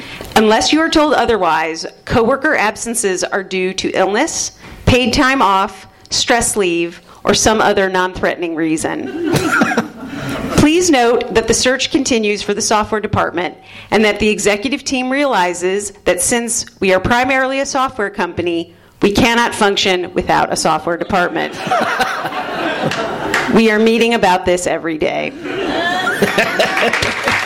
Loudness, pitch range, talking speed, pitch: -14 LUFS, 185-255 Hz, 130 wpm, 215 Hz